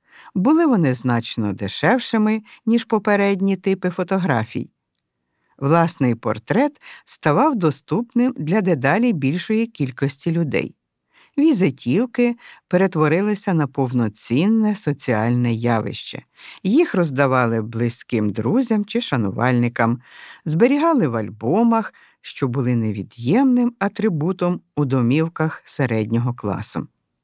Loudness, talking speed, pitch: -20 LUFS, 90 wpm, 155 Hz